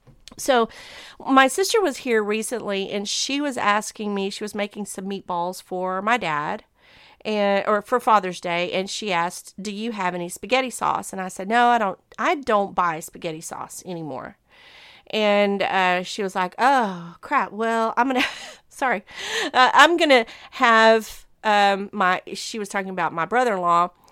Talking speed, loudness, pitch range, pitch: 170 wpm, -21 LUFS, 185-235 Hz, 205 Hz